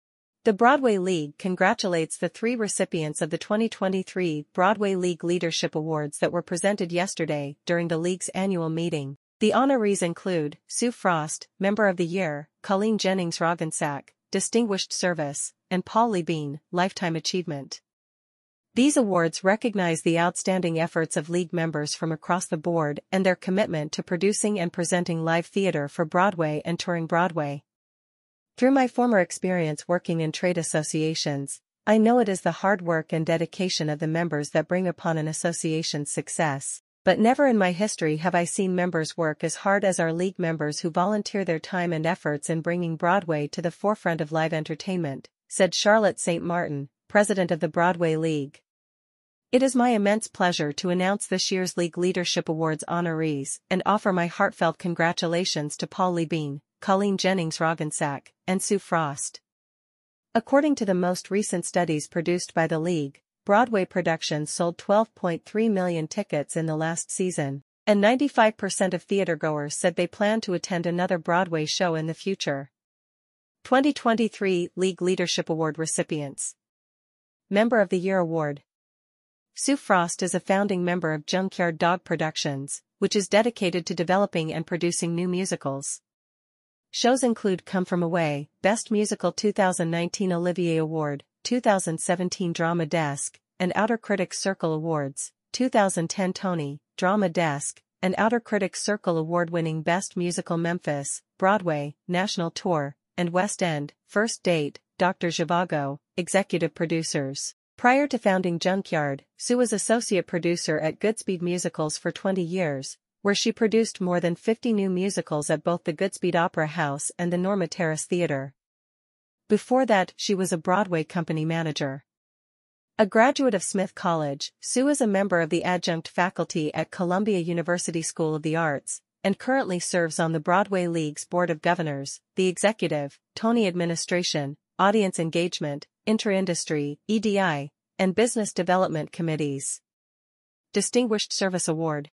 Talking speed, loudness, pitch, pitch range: 150 wpm, -25 LUFS, 175 Hz, 160-195 Hz